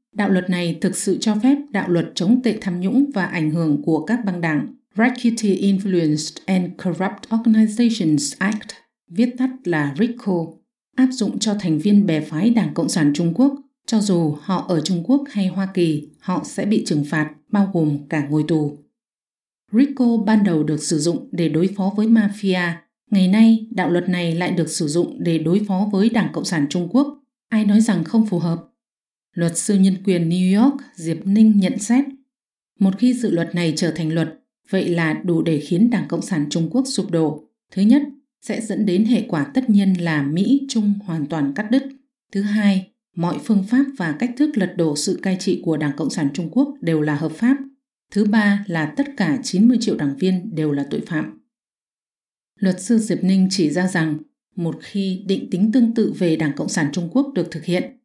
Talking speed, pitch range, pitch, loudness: 205 wpm, 165-225 Hz, 190 Hz, -19 LUFS